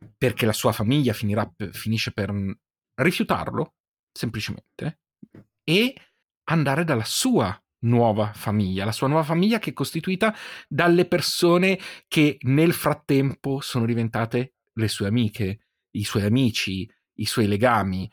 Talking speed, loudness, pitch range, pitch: 125 wpm, -23 LUFS, 105-150 Hz, 120 Hz